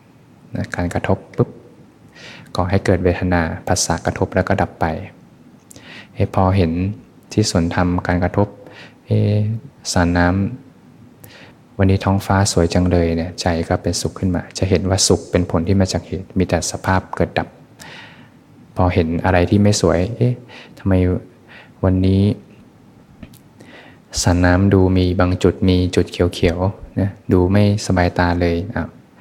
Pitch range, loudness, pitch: 90-100 Hz, -18 LUFS, 95 Hz